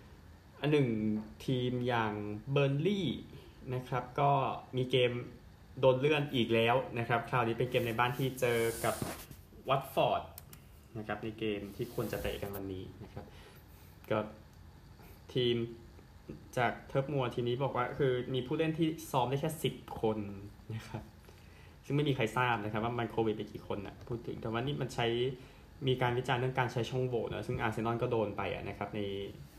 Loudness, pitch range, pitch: -34 LUFS, 105-130 Hz, 120 Hz